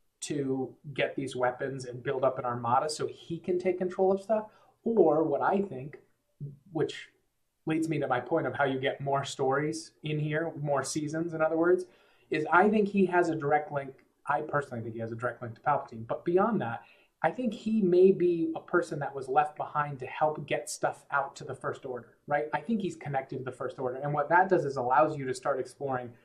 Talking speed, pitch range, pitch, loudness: 225 wpm, 135-175 Hz, 150 Hz, -30 LUFS